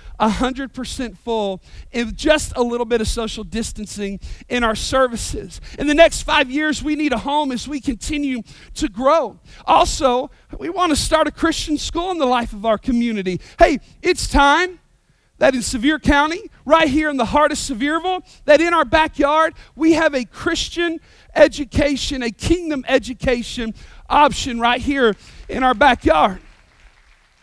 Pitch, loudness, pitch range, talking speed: 280 Hz, -18 LUFS, 240-310 Hz, 160 wpm